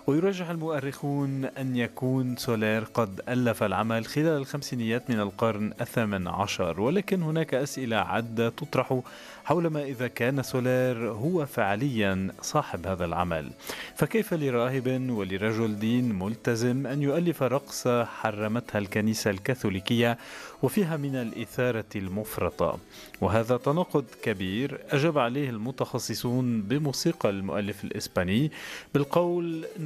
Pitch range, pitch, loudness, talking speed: 110-140 Hz, 125 Hz, -28 LUFS, 110 wpm